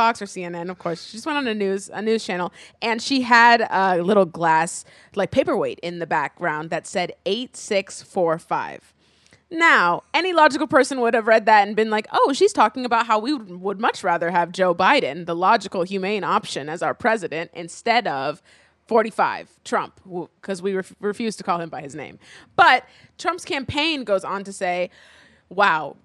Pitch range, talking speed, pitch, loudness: 180-235 Hz, 180 wpm, 200 Hz, -21 LUFS